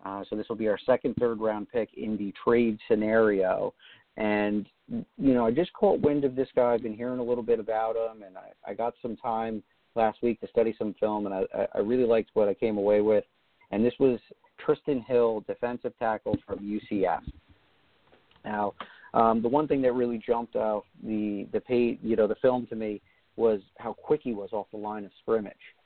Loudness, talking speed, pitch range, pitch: -28 LUFS, 210 wpm, 105-120 Hz, 115 Hz